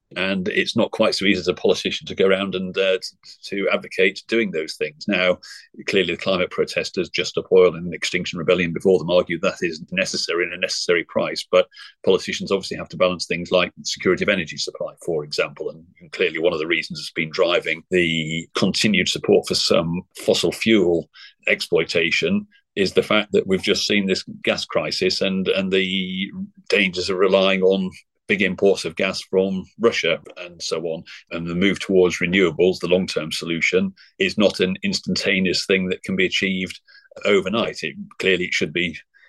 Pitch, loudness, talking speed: 100 Hz, -20 LUFS, 190 wpm